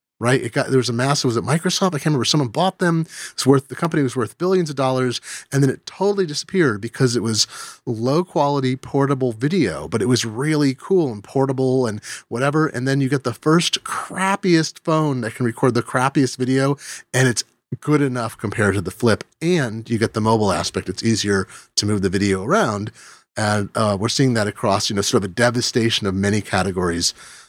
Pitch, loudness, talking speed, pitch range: 130 Hz, -20 LUFS, 210 wpm, 110-145 Hz